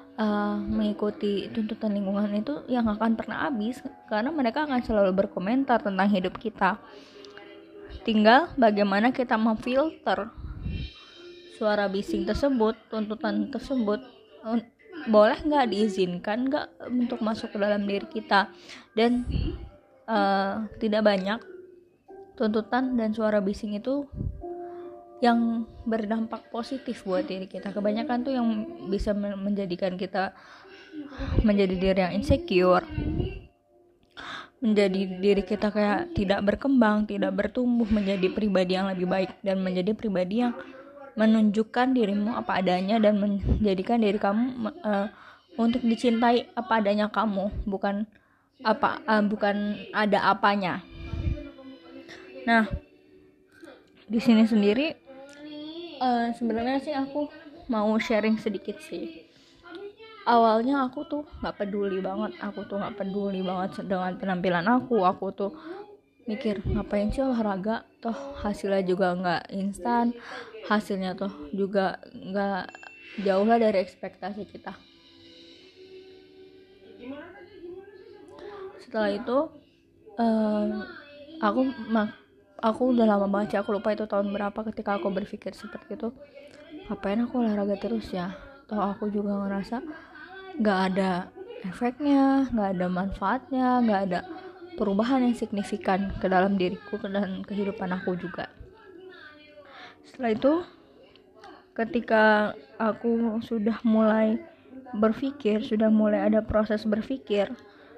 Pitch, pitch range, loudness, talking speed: 220 Hz, 200-255 Hz, -26 LUFS, 110 wpm